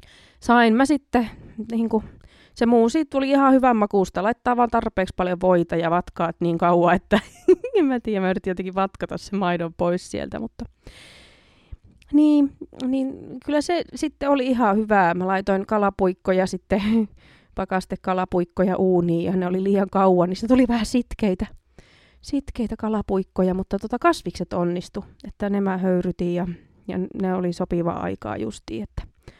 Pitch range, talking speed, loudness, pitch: 180-235 Hz, 155 wpm, -22 LUFS, 195 Hz